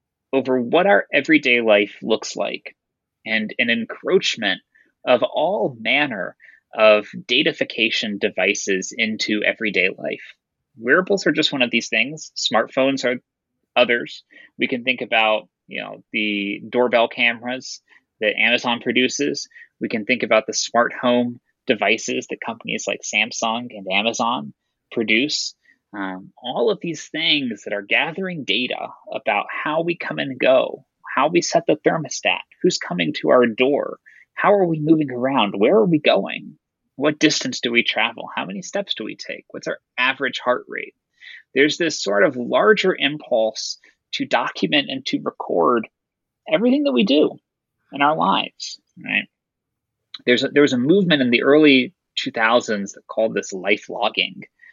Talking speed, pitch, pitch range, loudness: 155 wpm, 125 Hz, 115-155 Hz, -19 LUFS